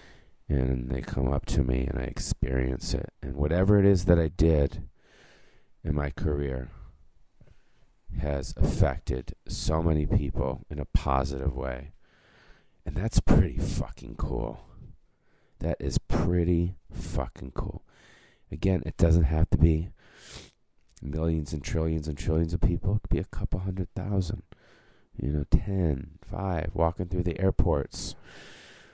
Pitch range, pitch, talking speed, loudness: 70-90 Hz, 80 Hz, 140 wpm, -28 LUFS